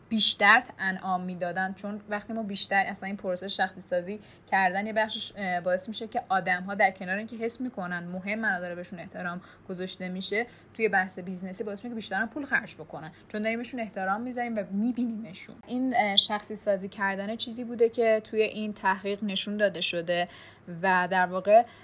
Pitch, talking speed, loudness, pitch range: 200 Hz, 175 wpm, -28 LUFS, 185-220 Hz